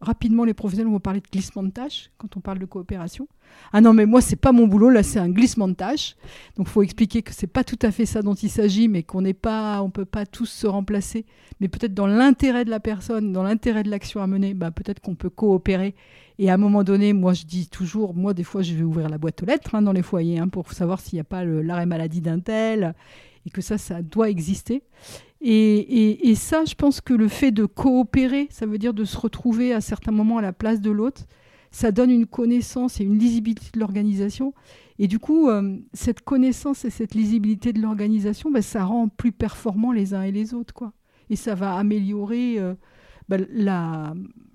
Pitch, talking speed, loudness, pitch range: 215 Hz, 235 wpm, -21 LUFS, 195-230 Hz